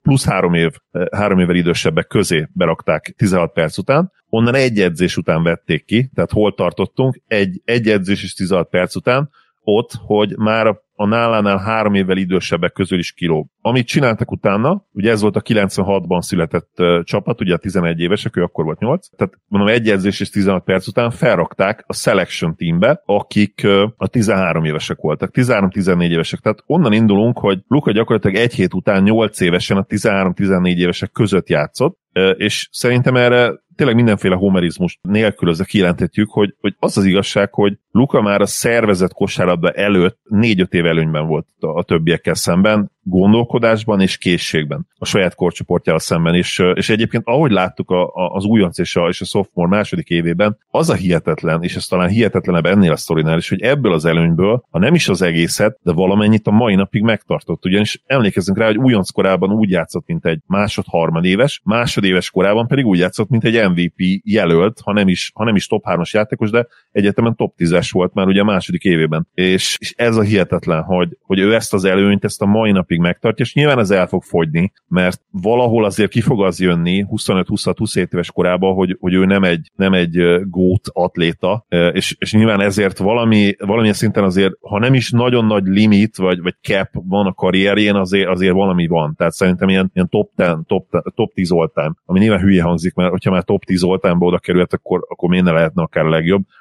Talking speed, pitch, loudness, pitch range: 190 wpm, 100 Hz, -15 LUFS, 90-110 Hz